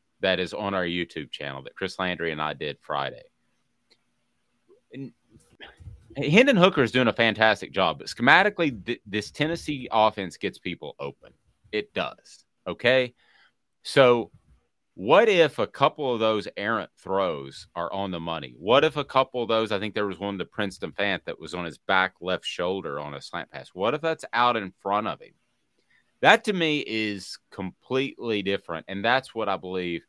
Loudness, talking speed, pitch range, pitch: -25 LUFS, 180 wpm, 95-130 Hz, 105 Hz